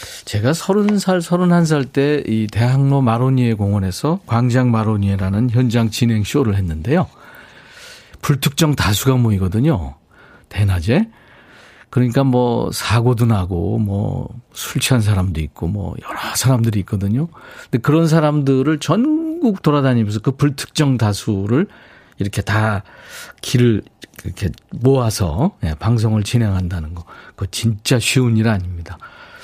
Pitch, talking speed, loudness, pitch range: 120 Hz, 285 characters per minute, -17 LUFS, 105-140 Hz